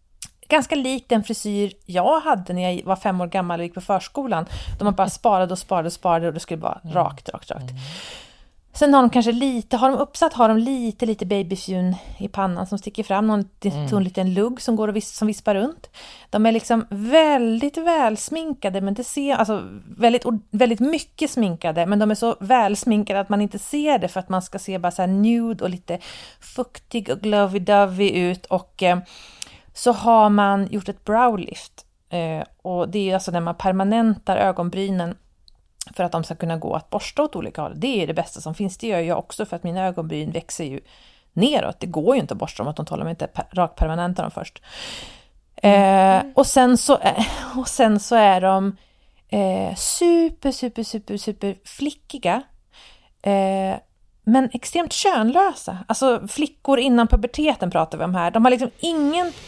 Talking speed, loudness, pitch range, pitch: 190 wpm, -21 LUFS, 185-245 Hz, 205 Hz